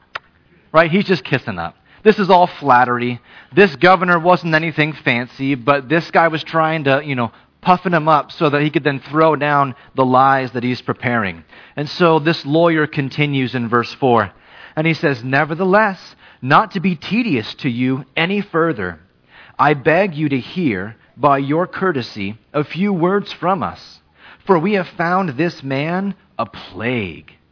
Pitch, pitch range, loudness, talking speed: 150 Hz, 130-175 Hz, -16 LUFS, 170 wpm